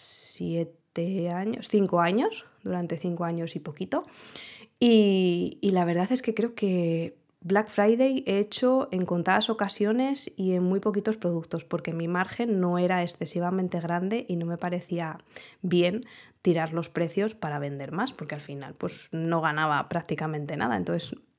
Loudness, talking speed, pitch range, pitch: -27 LUFS, 155 wpm, 165-205 Hz, 180 Hz